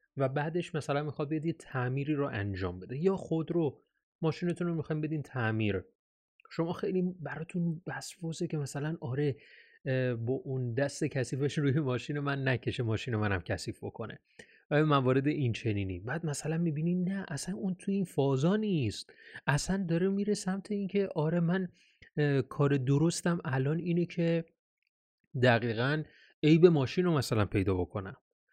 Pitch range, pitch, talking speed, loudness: 130-170 Hz, 150 Hz, 145 wpm, -32 LUFS